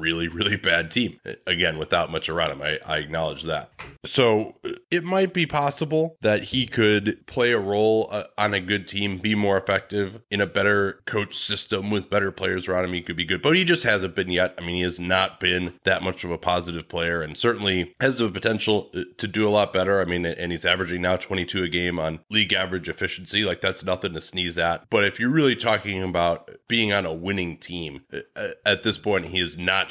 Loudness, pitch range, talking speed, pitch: -23 LUFS, 90-110 Hz, 220 wpm, 95 Hz